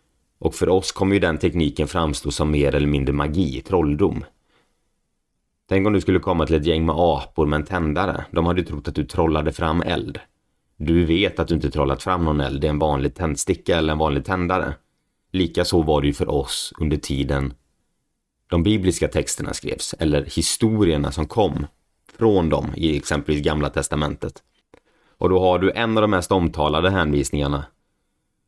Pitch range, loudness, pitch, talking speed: 75-90 Hz, -21 LUFS, 80 Hz, 180 wpm